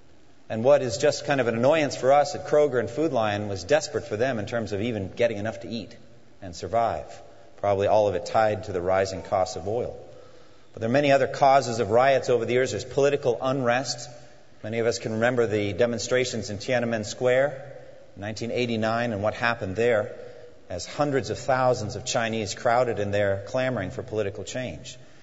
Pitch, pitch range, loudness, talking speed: 115 Hz, 105-125 Hz, -25 LUFS, 195 wpm